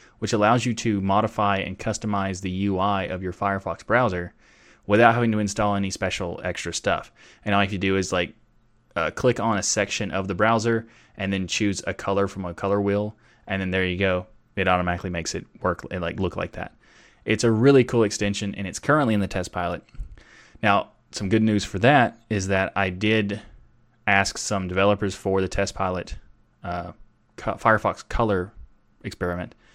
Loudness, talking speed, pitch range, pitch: -24 LUFS, 190 wpm, 95-110 Hz, 100 Hz